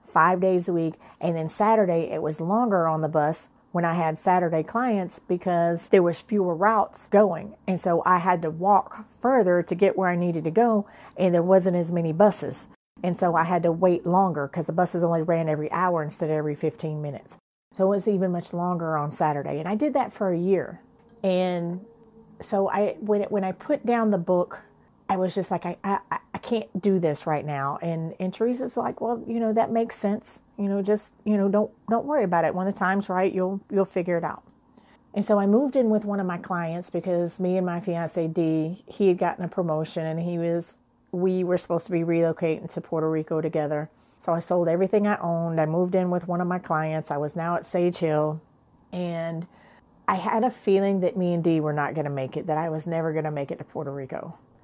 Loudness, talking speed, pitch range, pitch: -25 LUFS, 230 wpm, 165-200 Hz, 180 Hz